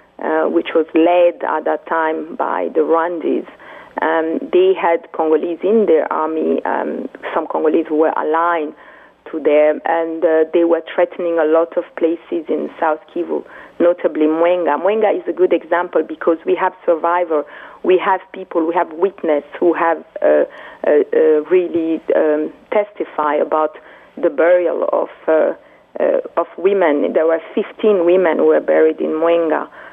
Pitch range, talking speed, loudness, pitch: 160-190 Hz, 160 wpm, -16 LUFS, 170 Hz